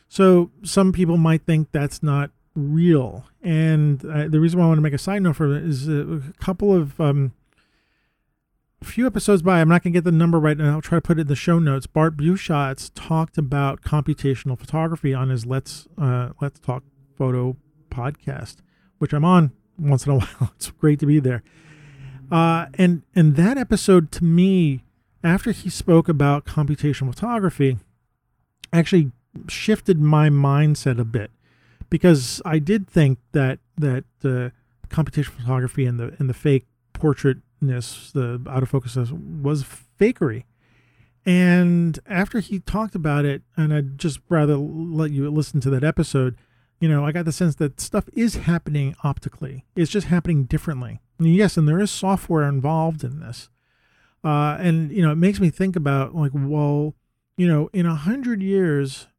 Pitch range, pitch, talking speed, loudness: 135-170 Hz, 150 Hz, 175 wpm, -20 LUFS